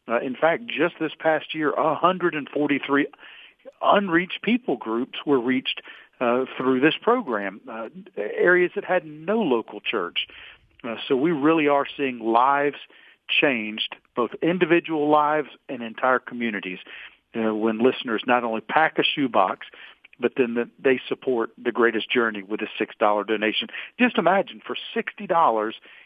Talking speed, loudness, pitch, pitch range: 145 wpm, -23 LUFS, 140 Hz, 115-165 Hz